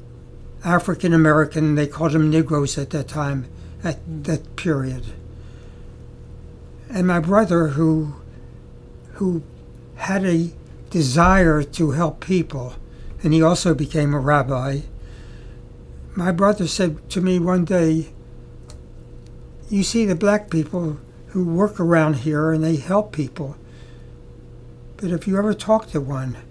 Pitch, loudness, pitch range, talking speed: 155 Hz, -20 LUFS, 135-180 Hz, 125 wpm